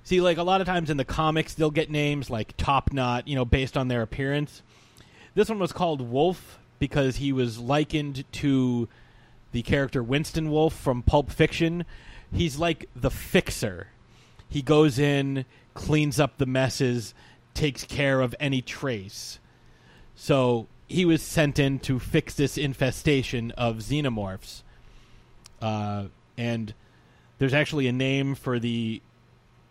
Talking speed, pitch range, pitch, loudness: 145 wpm, 120-150 Hz, 135 Hz, -26 LUFS